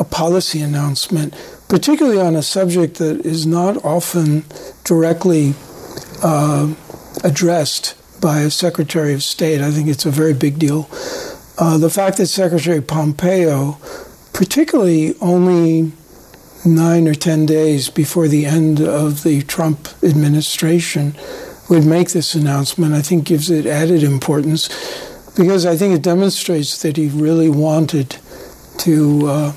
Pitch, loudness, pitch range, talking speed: 160 Hz, -15 LUFS, 150-175 Hz, 135 wpm